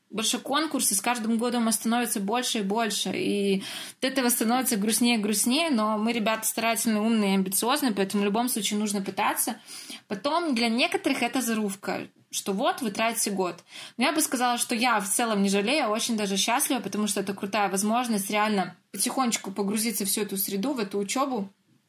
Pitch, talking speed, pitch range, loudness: 225 Hz, 185 wpm, 205-245 Hz, -26 LUFS